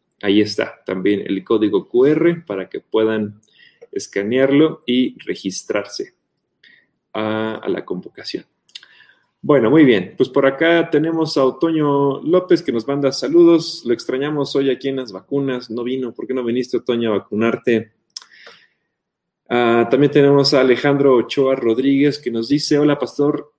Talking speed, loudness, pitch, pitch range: 150 wpm, -17 LUFS, 135 Hz, 115-145 Hz